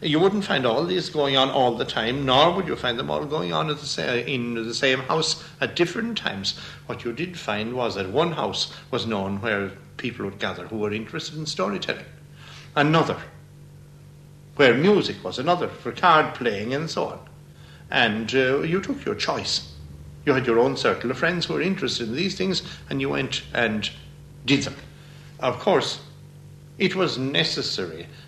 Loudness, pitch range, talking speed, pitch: -24 LUFS, 120-155 Hz, 185 wpm, 145 Hz